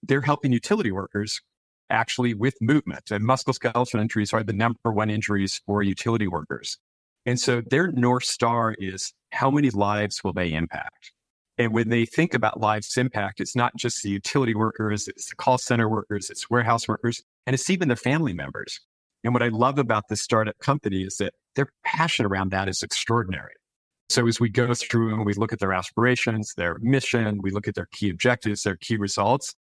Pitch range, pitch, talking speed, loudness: 105-125 Hz, 115 Hz, 190 wpm, -24 LUFS